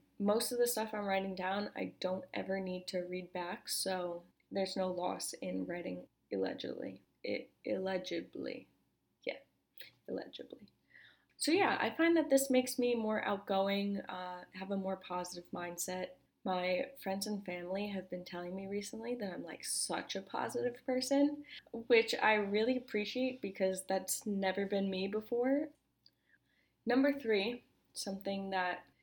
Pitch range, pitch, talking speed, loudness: 185-240 Hz, 195 Hz, 145 wpm, -37 LUFS